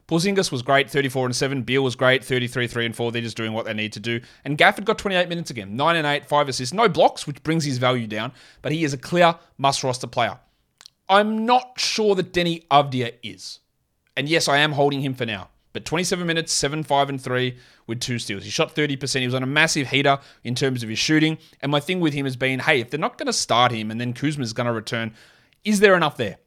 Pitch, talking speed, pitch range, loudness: 140 Hz, 250 wpm, 125-160 Hz, -21 LUFS